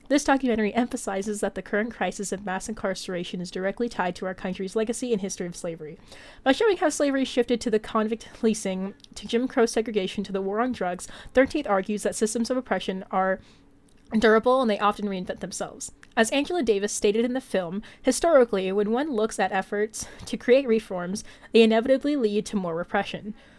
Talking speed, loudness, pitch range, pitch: 190 wpm, -25 LUFS, 195-240 Hz, 215 Hz